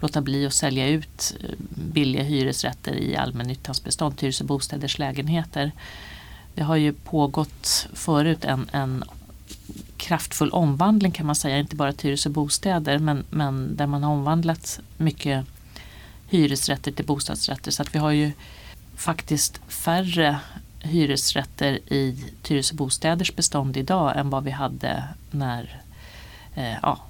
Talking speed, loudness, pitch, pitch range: 135 wpm, -24 LUFS, 145 Hz, 135-155 Hz